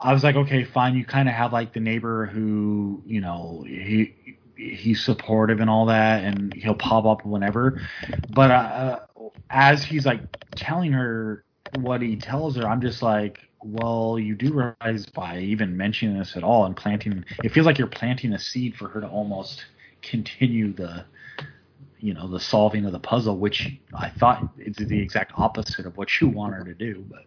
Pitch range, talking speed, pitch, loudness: 105-125 Hz, 190 wpm, 110 Hz, -23 LUFS